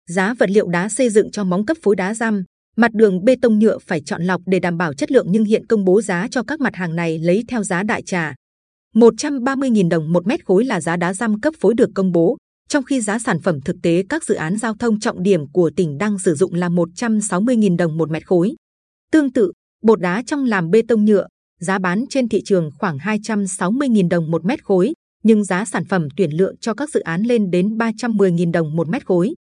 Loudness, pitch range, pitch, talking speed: -18 LUFS, 180-230 Hz, 200 Hz, 235 wpm